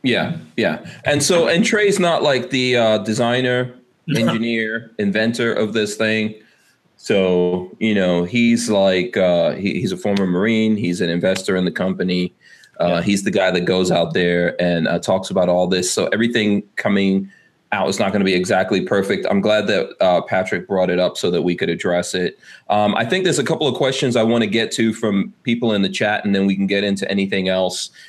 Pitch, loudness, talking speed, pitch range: 100 Hz, -18 LUFS, 210 wpm, 90-115 Hz